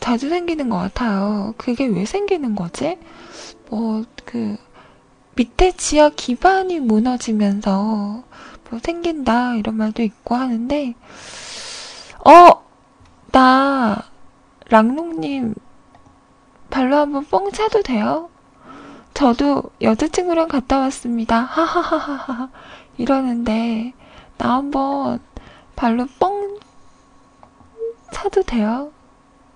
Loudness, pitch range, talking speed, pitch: -18 LUFS, 230-325 Hz, 185 characters per minute, 260 Hz